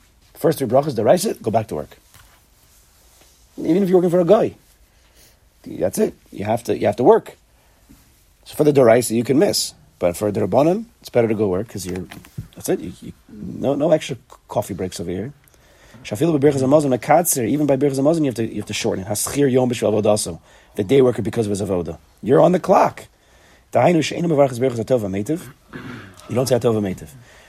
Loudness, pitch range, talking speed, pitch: -19 LUFS, 105-140 Hz, 175 wpm, 120 Hz